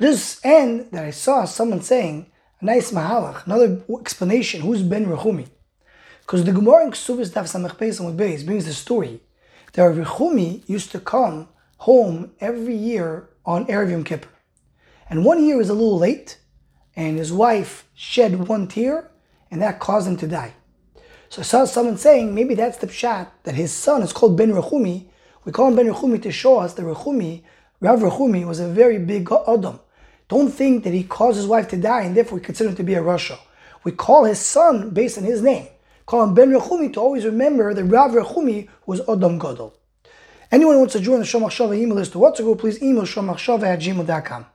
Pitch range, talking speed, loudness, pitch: 180-245 Hz, 195 wpm, -18 LUFS, 220 Hz